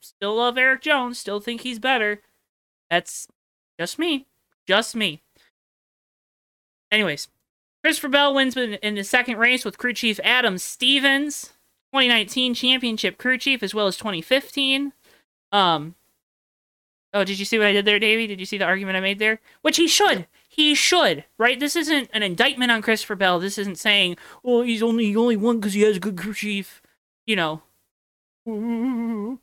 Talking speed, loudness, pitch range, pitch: 170 wpm, -20 LUFS, 205-260 Hz, 230 Hz